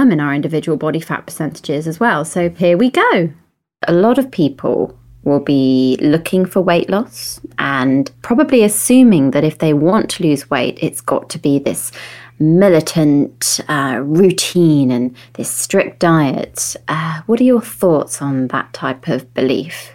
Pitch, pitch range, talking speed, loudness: 155 Hz, 140-185 Hz, 160 wpm, -15 LUFS